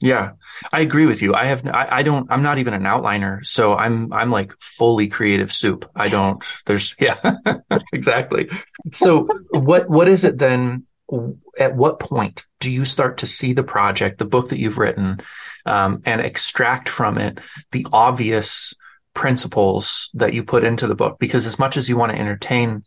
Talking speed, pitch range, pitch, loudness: 185 wpm, 105-135 Hz, 125 Hz, -18 LUFS